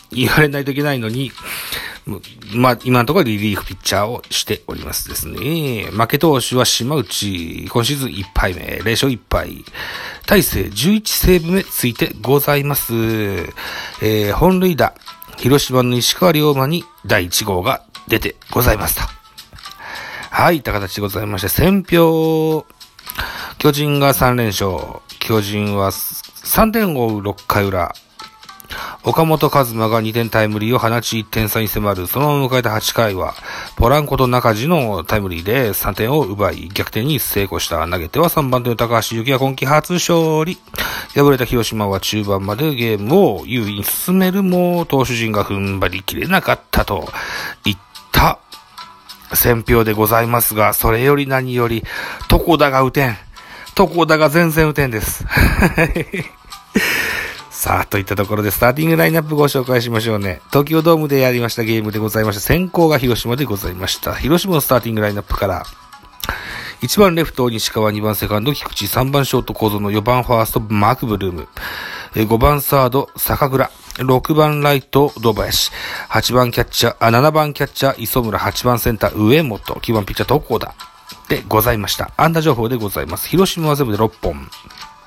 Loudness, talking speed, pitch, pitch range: -16 LUFS, 320 characters per minute, 120 Hz, 105-145 Hz